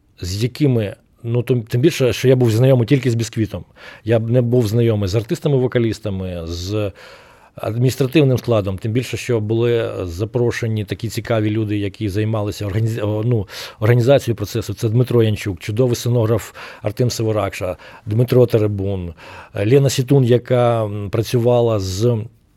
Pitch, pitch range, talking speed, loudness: 115 Hz, 105-125 Hz, 135 wpm, -18 LUFS